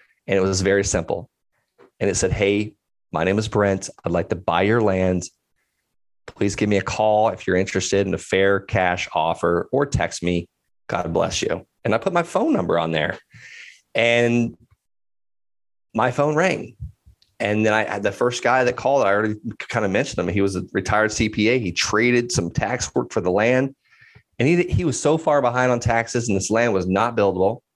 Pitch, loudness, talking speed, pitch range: 105 Hz, -21 LUFS, 200 wpm, 95-120 Hz